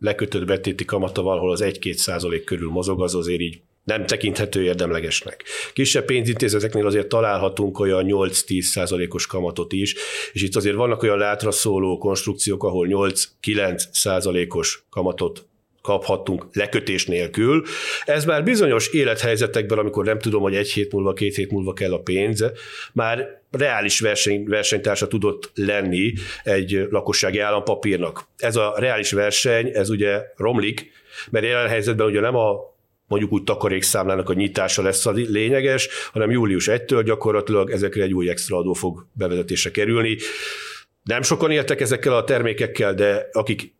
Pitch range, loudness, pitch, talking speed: 95-110 Hz, -21 LUFS, 100 Hz, 145 wpm